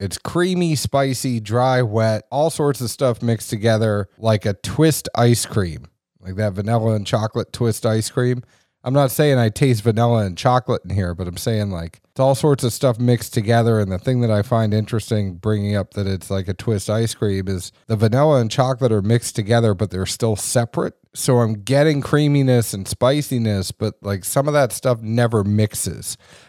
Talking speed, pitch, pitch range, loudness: 195 wpm, 115 Hz, 105-125 Hz, -19 LUFS